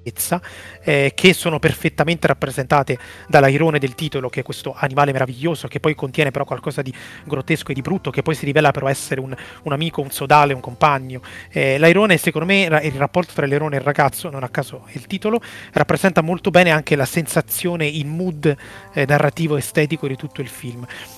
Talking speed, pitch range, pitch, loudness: 190 wpm, 135-160 Hz, 145 Hz, -18 LUFS